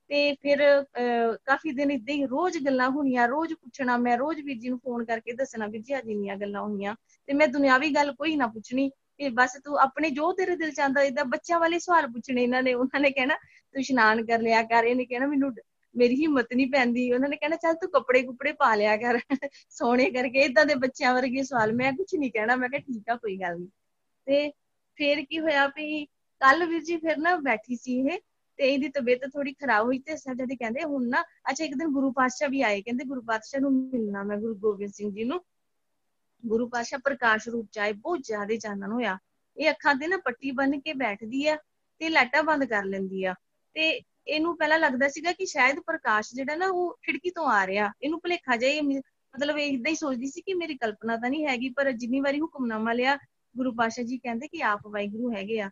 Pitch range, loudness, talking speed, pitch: 235-295 Hz, -26 LUFS, 210 wpm, 270 Hz